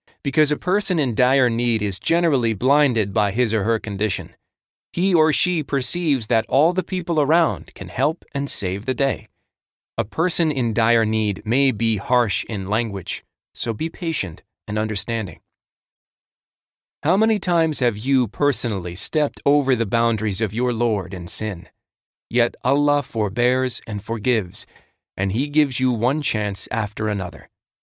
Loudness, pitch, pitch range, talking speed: -20 LUFS, 120 Hz, 105-145 Hz, 155 wpm